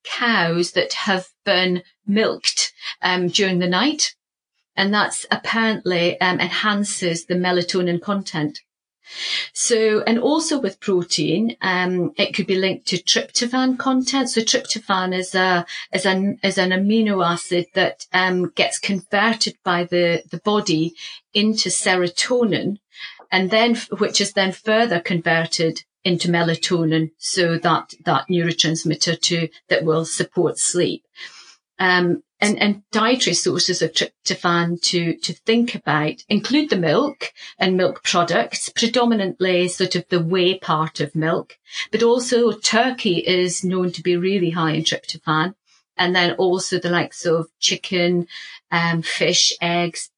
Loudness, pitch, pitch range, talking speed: -19 LUFS, 185 Hz, 170-205 Hz, 135 wpm